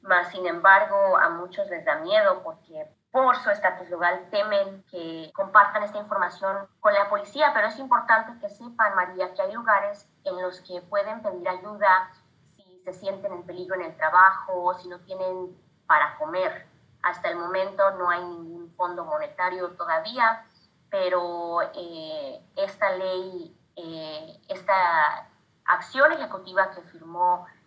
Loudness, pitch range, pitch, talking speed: -24 LUFS, 180-225 Hz, 190 Hz, 145 wpm